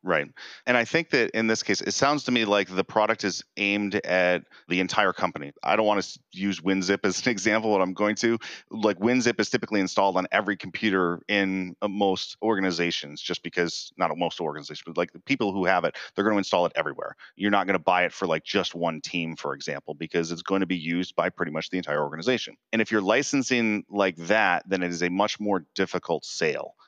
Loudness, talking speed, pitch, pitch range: -25 LUFS, 230 wpm, 100 Hz, 90-110 Hz